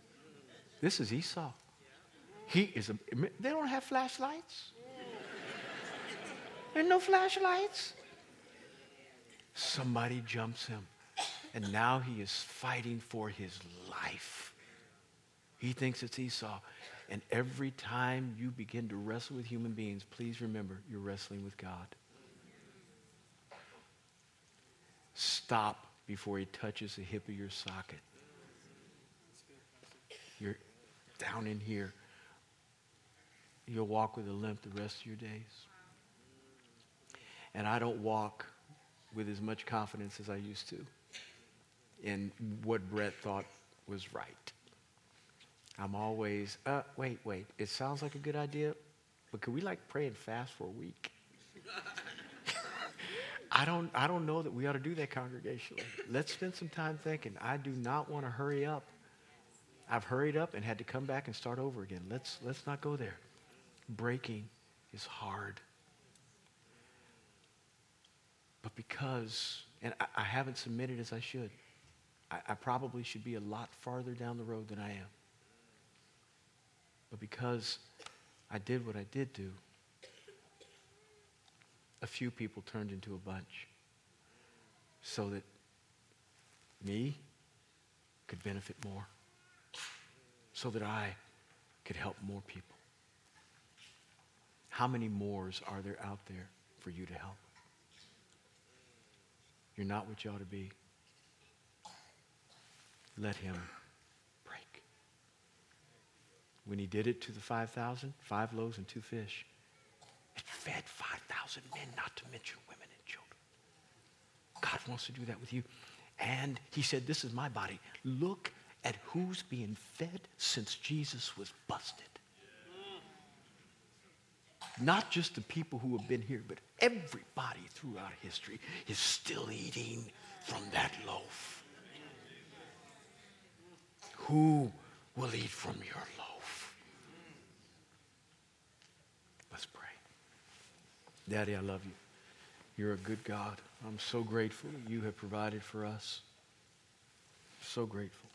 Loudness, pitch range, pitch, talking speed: -40 LUFS, 105-130 Hz, 115 Hz, 125 wpm